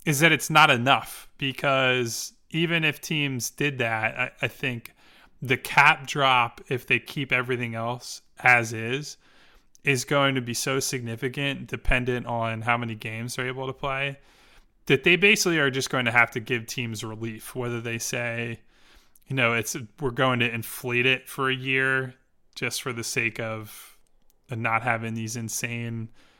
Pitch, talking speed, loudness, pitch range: 125 Hz, 170 wpm, -24 LUFS, 115-135 Hz